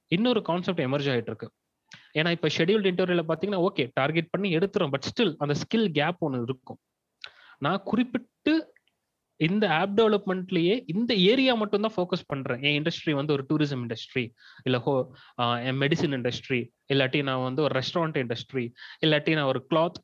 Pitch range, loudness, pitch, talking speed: 130-190 Hz, -26 LUFS, 155 Hz, 150 wpm